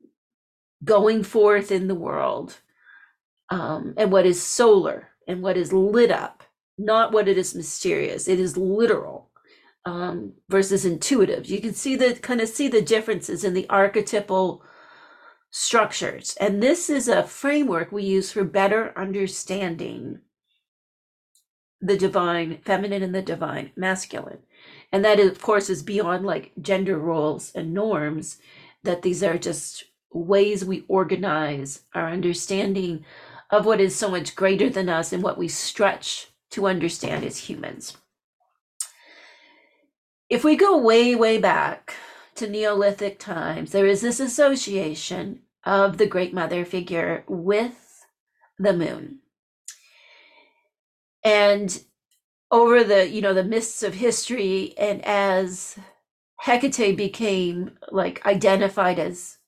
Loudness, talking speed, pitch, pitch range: -22 LUFS, 130 wpm, 200 Hz, 185-225 Hz